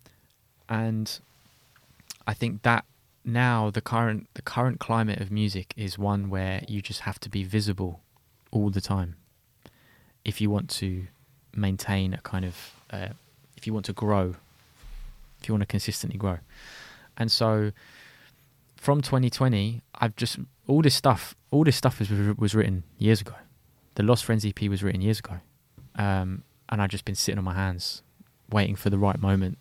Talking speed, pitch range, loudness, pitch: 170 wpm, 100-120 Hz, -27 LUFS, 105 Hz